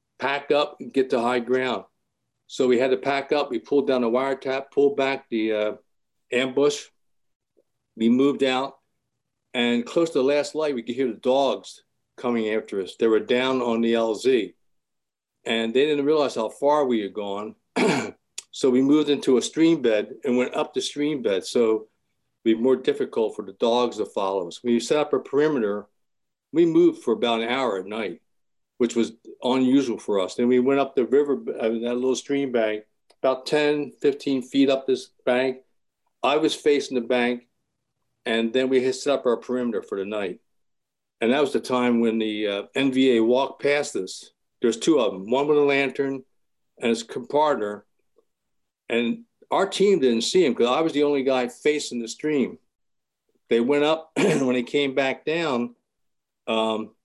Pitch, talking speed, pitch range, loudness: 130 Hz, 190 wpm, 120-145 Hz, -23 LUFS